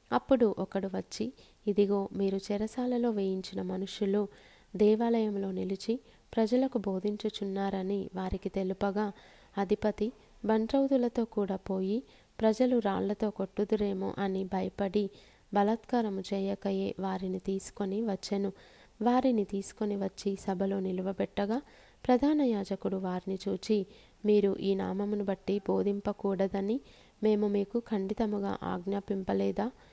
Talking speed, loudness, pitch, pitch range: 90 wpm, -32 LUFS, 200 Hz, 195-215 Hz